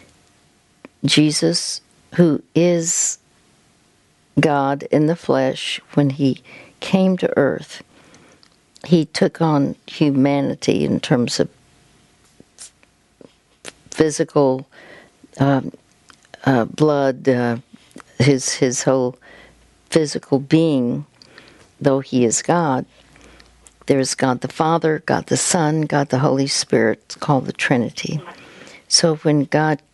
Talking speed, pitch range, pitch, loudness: 100 wpm, 130-160 Hz, 145 Hz, -18 LUFS